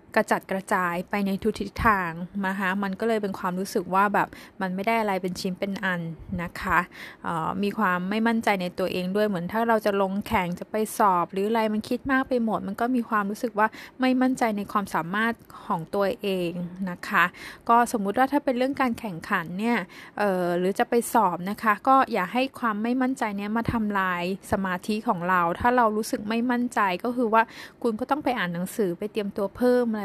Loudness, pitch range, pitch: -25 LUFS, 190-235 Hz, 210 Hz